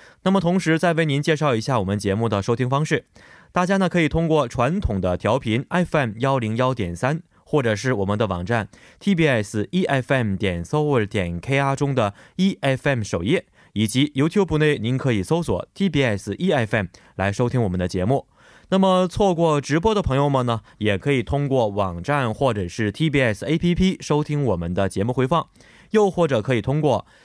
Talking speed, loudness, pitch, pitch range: 310 characters per minute, -21 LUFS, 135 Hz, 110-155 Hz